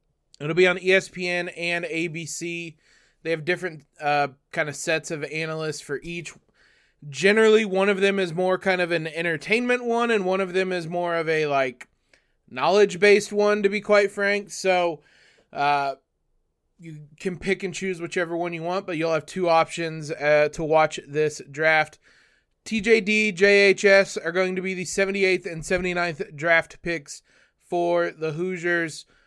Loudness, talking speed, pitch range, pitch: -23 LUFS, 165 wpm, 160-190 Hz, 175 Hz